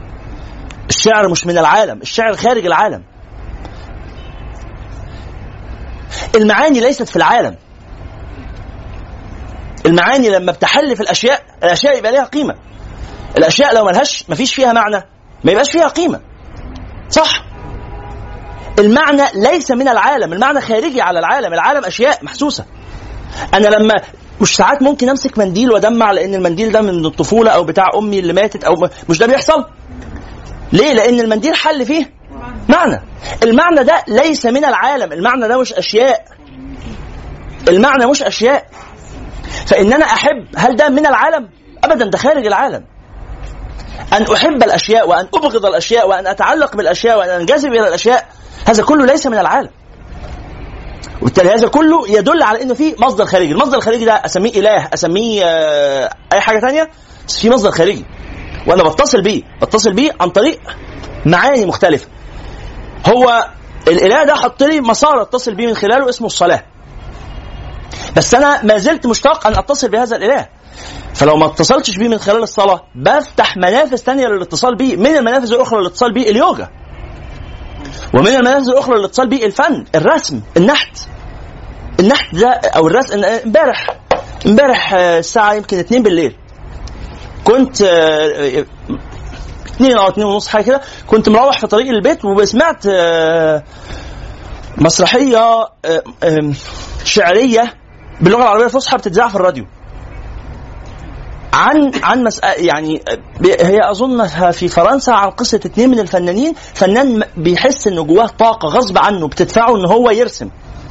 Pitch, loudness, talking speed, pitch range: 215 Hz, -11 LUFS, 135 wpm, 170-255 Hz